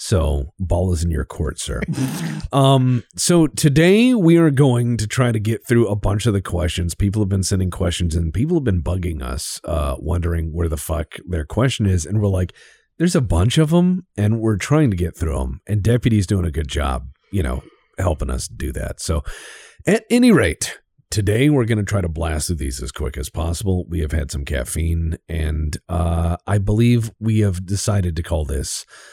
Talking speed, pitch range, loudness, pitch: 210 wpm, 85-120 Hz, -19 LUFS, 95 Hz